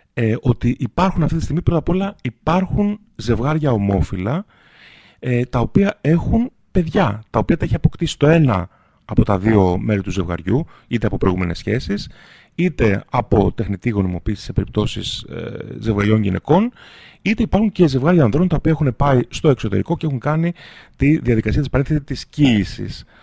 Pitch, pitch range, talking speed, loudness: 125 Hz, 105-160 Hz, 160 wpm, -18 LUFS